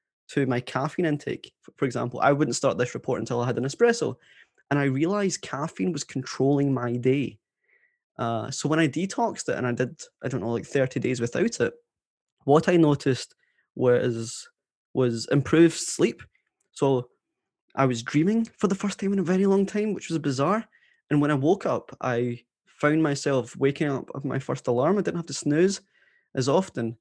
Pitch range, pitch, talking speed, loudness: 125-175 Hz, 140 Hz, 190 wpm, -25 LUFS